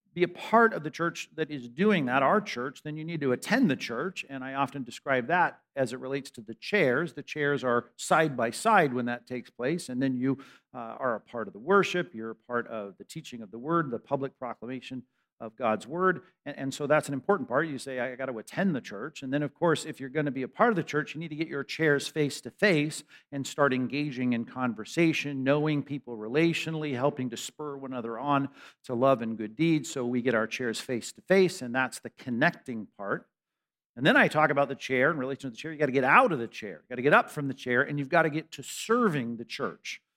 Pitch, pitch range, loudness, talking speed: 140 Hz, 125-155 Hz, -28 LUFS, 255 wpm